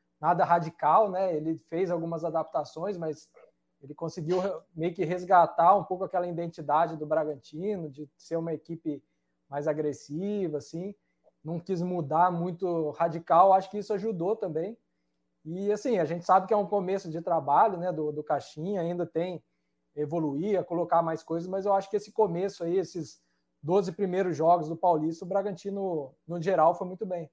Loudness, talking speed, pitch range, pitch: -28 LUFS, 175 wpm, 155-190 Hz, 170 Hz